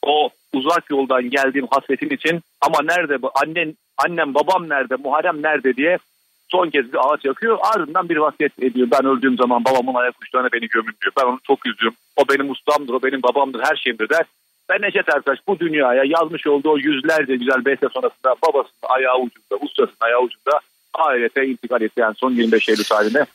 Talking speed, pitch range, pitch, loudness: 185 wpm, 130-150 Hz, 135 Hz, -18 LUFS